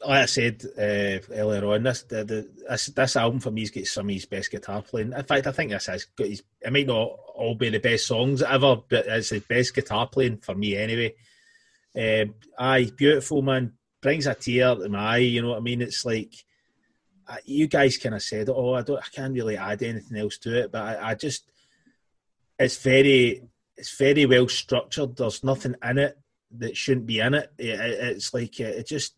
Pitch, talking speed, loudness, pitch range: 120 Hz, 220 wpm, -24 LUFS, 110-135 Hz